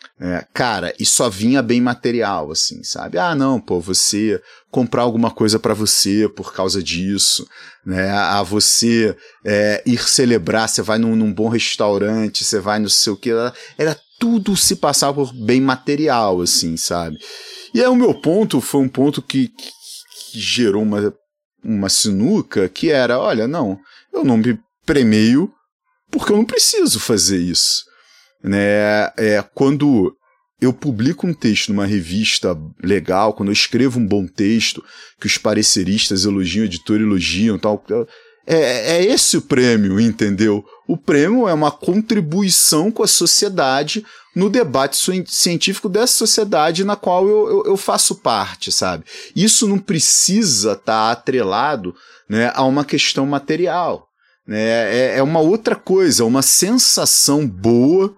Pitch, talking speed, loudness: 125 Hz, 150 wpm, -15 LUFS